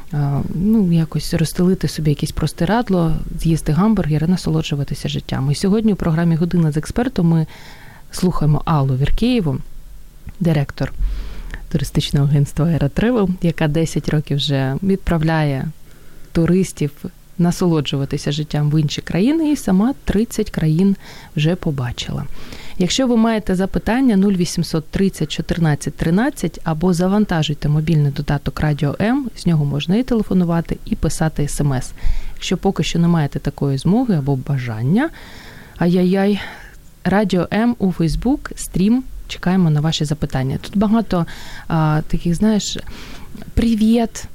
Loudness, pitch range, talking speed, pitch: -18 LUFS, 150-195 Hz, 120 wpm, 170 Hz